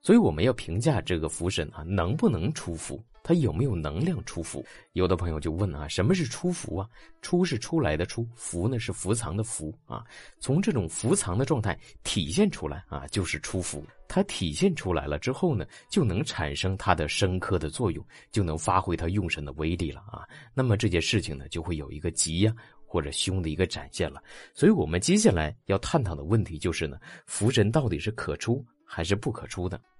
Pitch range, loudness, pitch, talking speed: 80-120 Hz, -28 LUFS, 95 Hz, 310 characters per minute